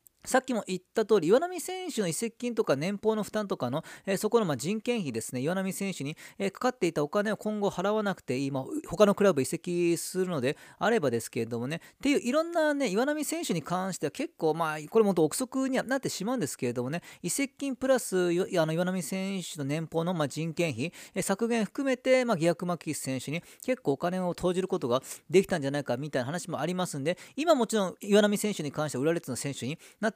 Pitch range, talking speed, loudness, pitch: 155-220 Hz, 430 characters per minute, -29 LUFS, 185 Hz